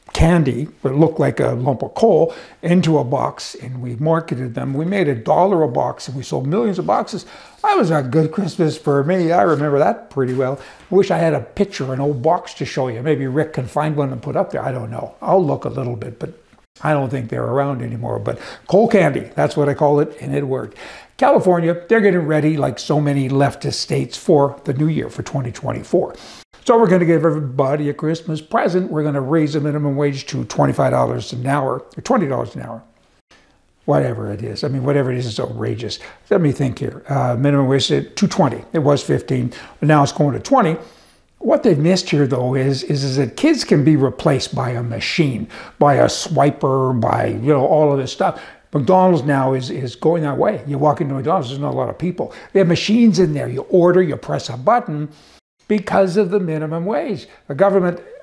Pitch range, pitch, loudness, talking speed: 135-170 Hz, 150 Hz, -18 LUFS, 220 wpm